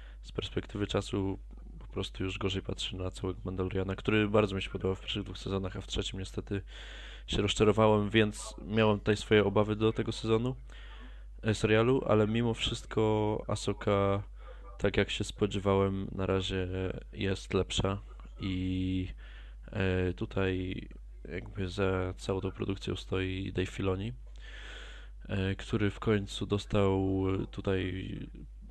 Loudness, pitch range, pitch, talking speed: -32 LUFS, 95-105 Hz, 100 Hz, 135 wpm